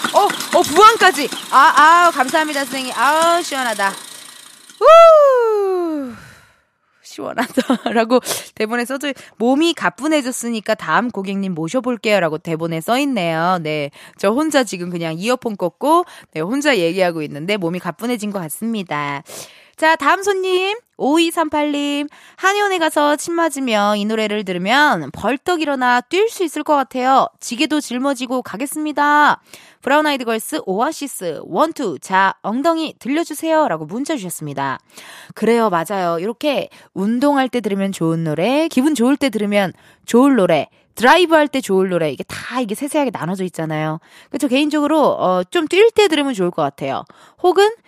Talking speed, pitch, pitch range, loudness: 320 characters per minute, 260 Hz, 195-310 Hz, -16 LUFS